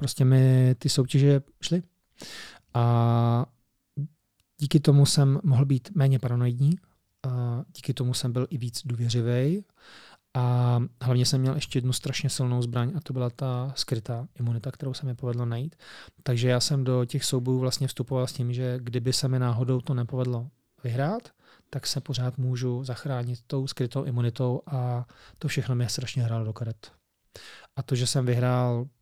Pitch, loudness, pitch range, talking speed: 130 Hz, -26 LUFS, 120-135 Hz, 165 wpm